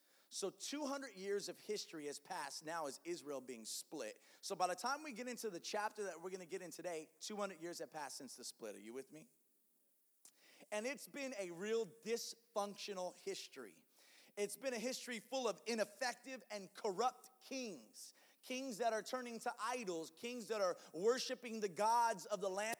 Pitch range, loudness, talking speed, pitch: 190-255 Hz, -44 LUFS, 190 wpm, 220 Hz